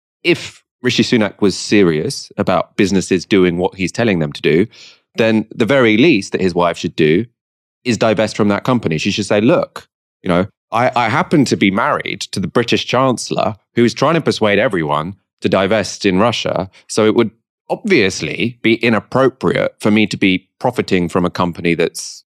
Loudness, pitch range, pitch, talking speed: -15 LUFS, 90-115 Hz, 105 Hz, 185 wpm